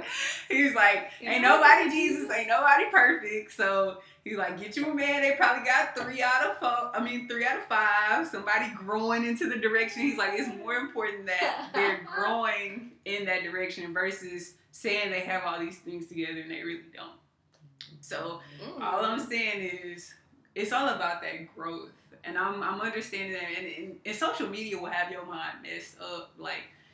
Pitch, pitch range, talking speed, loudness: 205 Hz, 175-235 Hz, 185 wpm, -27 LUFS